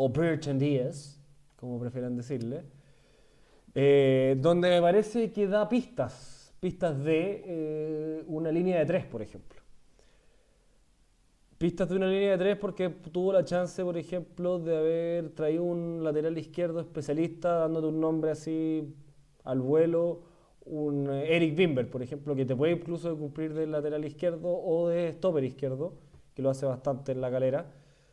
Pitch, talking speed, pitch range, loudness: 155 Hz, 155 wpm, 140-170 Hz, -29 LUFS